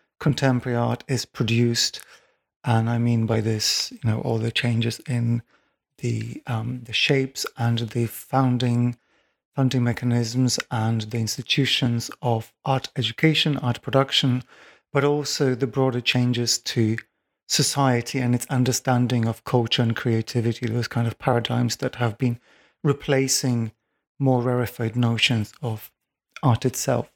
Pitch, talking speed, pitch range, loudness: 120 Hz, 135 wpm, 115-130 Hz, -23 LUFS